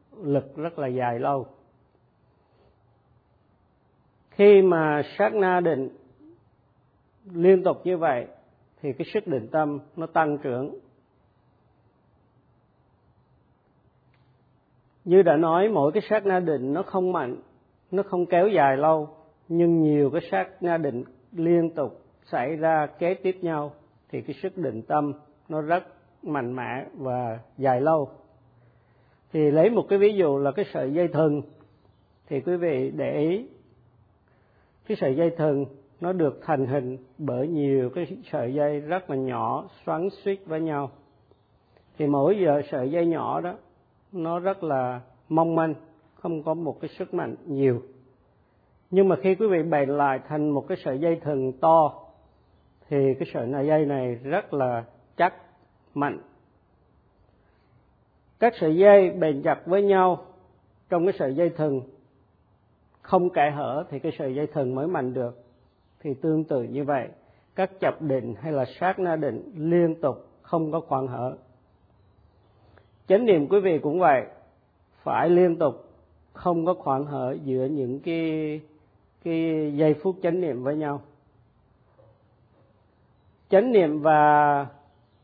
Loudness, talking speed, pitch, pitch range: -24 LUFS, 145 wpm, 150 Hz, 130-170 Hz